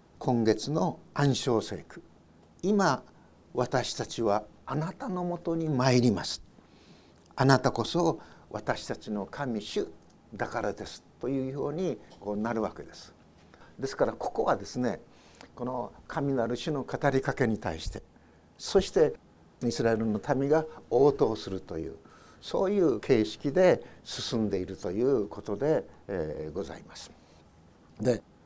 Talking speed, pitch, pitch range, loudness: 255 characters per minute, 120 Hz, 105-140 Hz, -30 LUFS